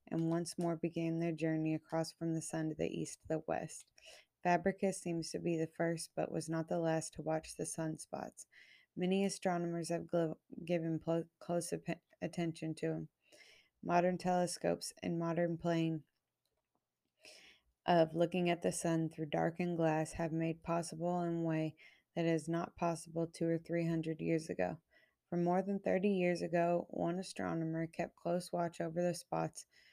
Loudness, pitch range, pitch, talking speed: -38 LUFS, 160-175 Hz, 165 Hz, 170 wpm